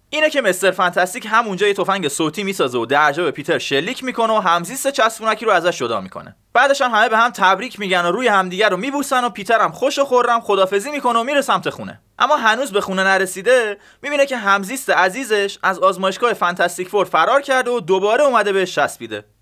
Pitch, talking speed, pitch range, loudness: 205 Hz, 205 wpm, 185-245 Hz, -17 LUFS